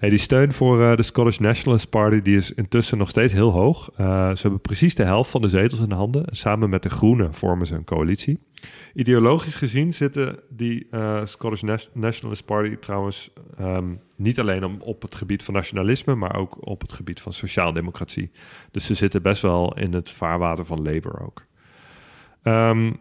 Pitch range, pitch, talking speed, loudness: 95-120 Hz, 105 Hz, 190 wpm, -21 LUFS